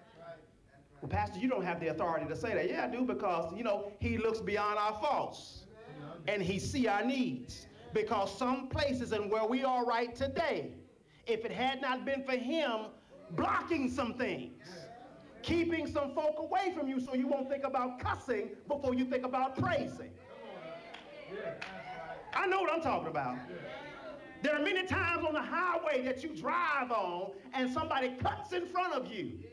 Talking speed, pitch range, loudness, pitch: 175 wpm, 210-290 Hz, -35 LUFS, 255 Hz